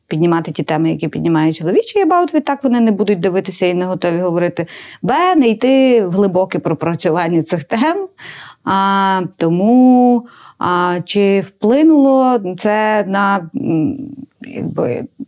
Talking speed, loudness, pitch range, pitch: 125 wpm, -14 LUFS, 175-255 Hz, 195 Hz